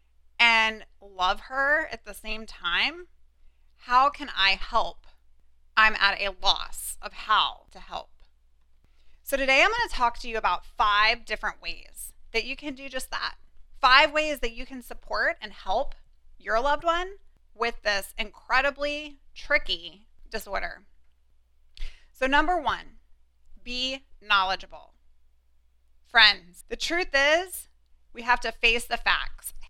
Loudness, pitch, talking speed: -24 LUFS, 220 Hz, 135 wpm